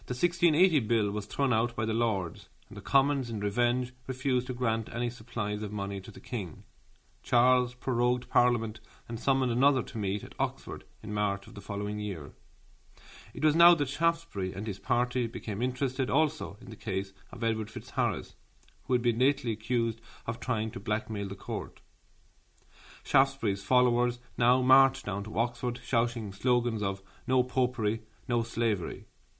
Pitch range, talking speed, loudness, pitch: 105-125 Hz, 170 wpm, -30 LUFS, 115 Hz